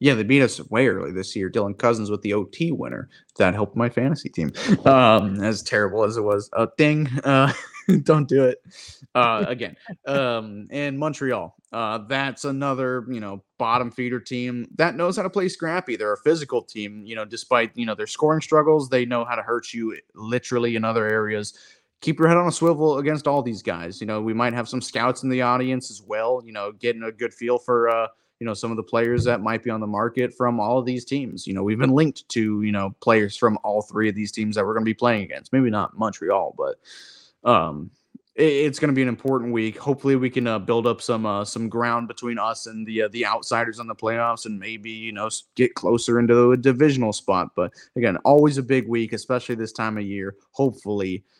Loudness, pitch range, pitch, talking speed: -22 LUFS, 110-135 Hz, 120 Hz, 230 wpm